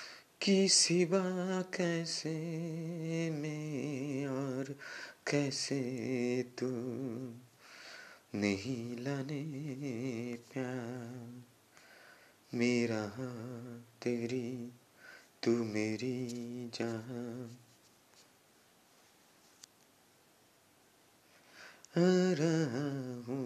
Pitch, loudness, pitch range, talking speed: 125 Hz, -36 LUFS, 120-150 Hz, 40 wpm